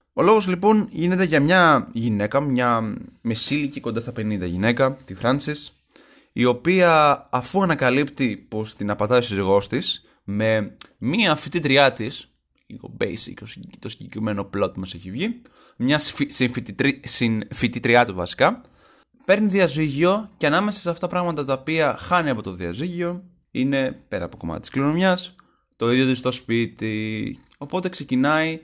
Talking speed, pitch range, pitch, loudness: 150 wpm, 115-170 Hz, 135 Hz, -21 LUFS